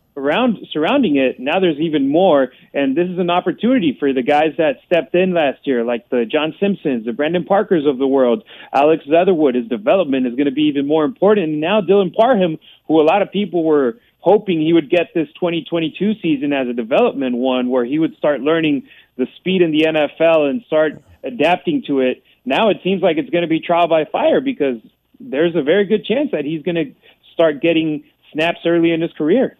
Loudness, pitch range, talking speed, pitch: -16 LUFS, 140-180 Hz, 215 wpm, 160 Hz